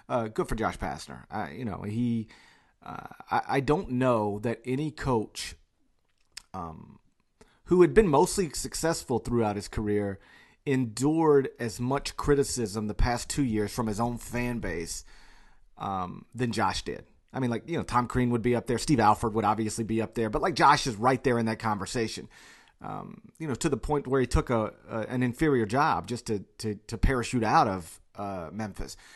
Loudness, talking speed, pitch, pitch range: -28 LUFS, 190 wpm, 120 Hz, 105-130 Hz